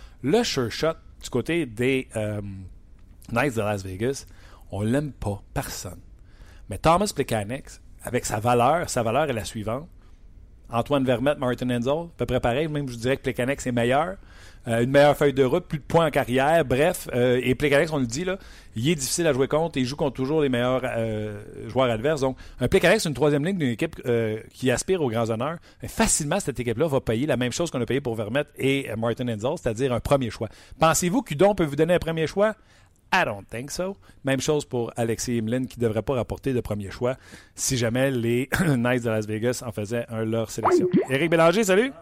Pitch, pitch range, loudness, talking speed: 125 Hz, 110-145 Hz, -24 LUFS, 215 wpm